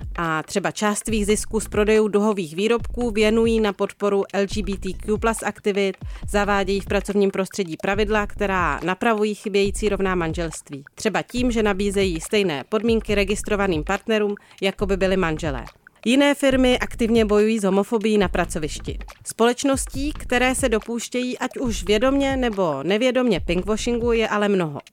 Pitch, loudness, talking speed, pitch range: 205 Hz, -21 LUFS, 135 wpm, 195-225 Hz